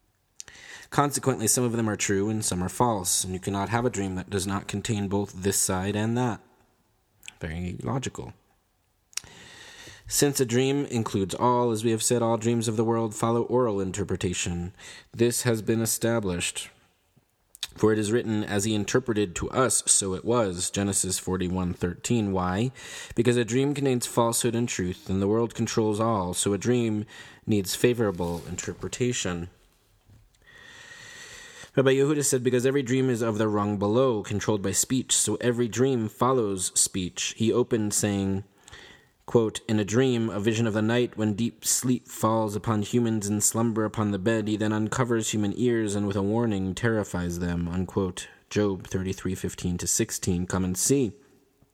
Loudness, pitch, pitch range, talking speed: -26 LUFS, 110 Hz, 100-120 Hz, 165 wpm